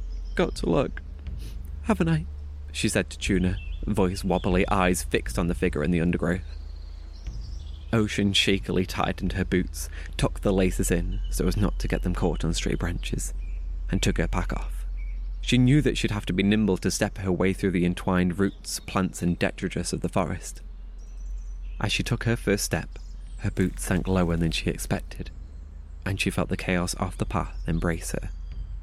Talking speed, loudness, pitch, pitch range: 185 wpm, -26 LUFS, 90 Hz, 75-95 Hz